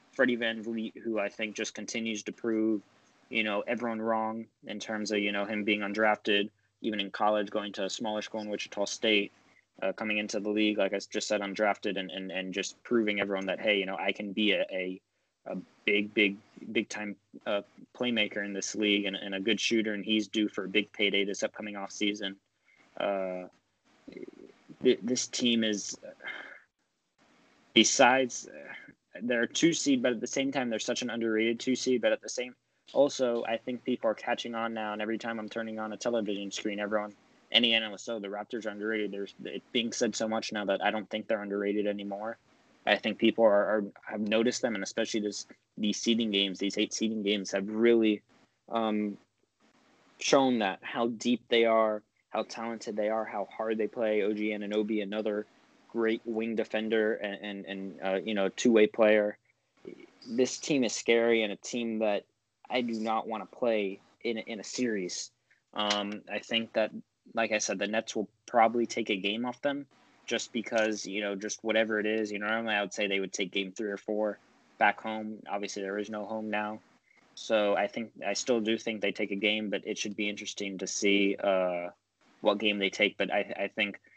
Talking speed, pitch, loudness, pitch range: 205 wpm, 105 Hz, -30 LUFS, 100-115 Hz